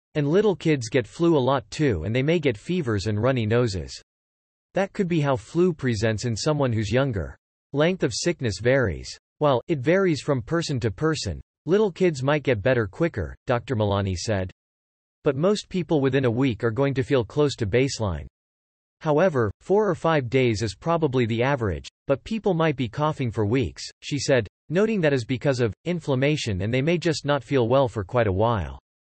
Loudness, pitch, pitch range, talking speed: -24 LUFS, 130 Hz, 110-155 Hz, 195 wpm